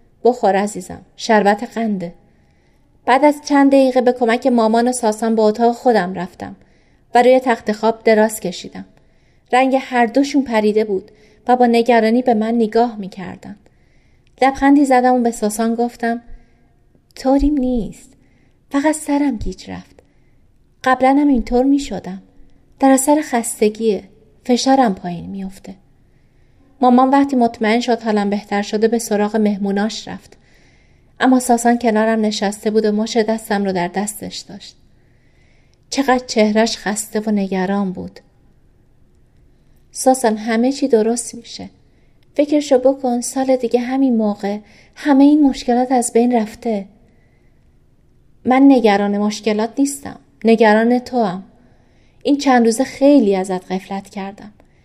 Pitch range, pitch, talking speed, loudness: 210-255 Hz, 230 Hz, 125 wpm, -16 LUFS